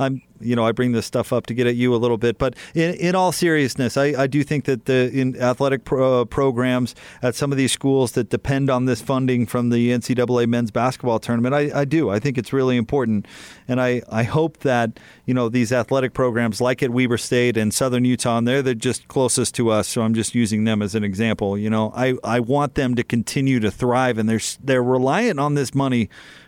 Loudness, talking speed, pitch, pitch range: -20 LUFS, 235 wpm, 125 Hz, 120-135 Hz